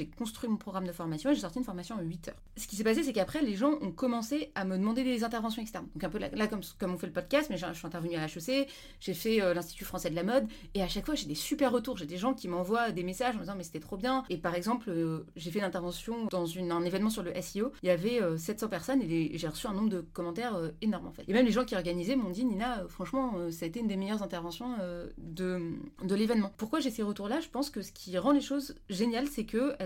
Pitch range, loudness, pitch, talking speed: 180-245 Hz, -33 LUFS, 205 Hz, 275 wpm